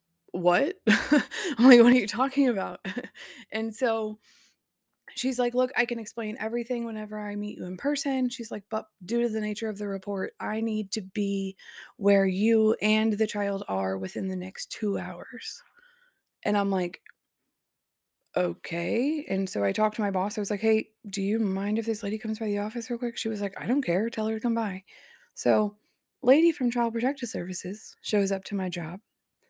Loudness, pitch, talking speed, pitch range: -27 LUFS, 215 Hz, 195 wpm, 200-240 Hz